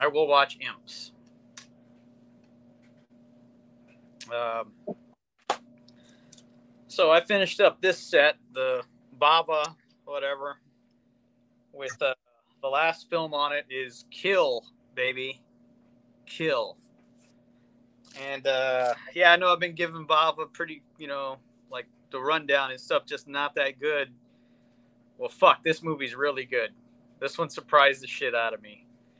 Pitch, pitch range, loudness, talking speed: 120 Hz, 120-145 Hz, -26 LUFS, 125 wpm